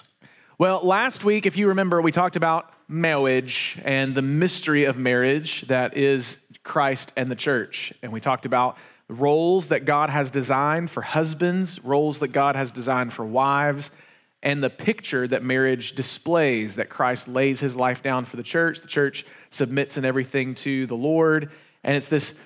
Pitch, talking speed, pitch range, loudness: 140 Hz, 175 wpm, 130-160 Hz, -23 LUFS